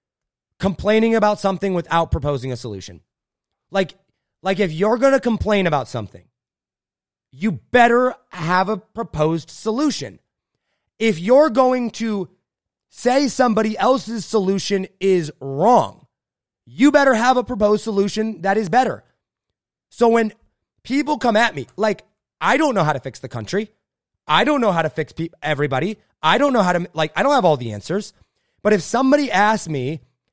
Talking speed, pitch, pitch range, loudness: 160 wpm, 200 Hz, 155-230 Hz, -19 LUFS